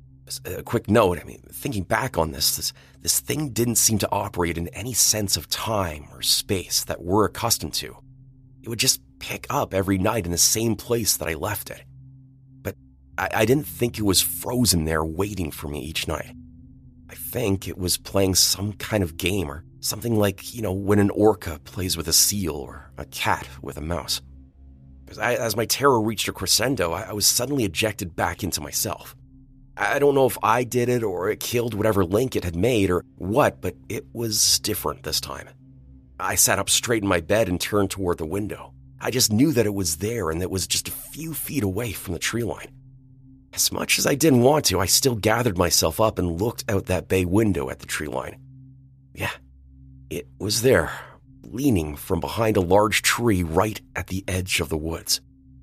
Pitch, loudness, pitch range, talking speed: 100 Hz, -22 LUFS, 85-115 Hz, 210 wpm